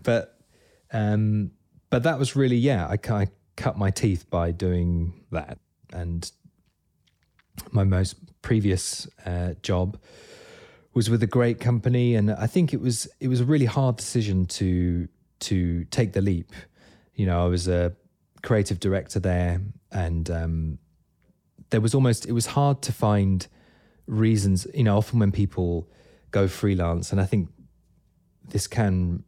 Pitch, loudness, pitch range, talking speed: 100 Hz, -25 LUFS, 90-120 Hz, 150 wpm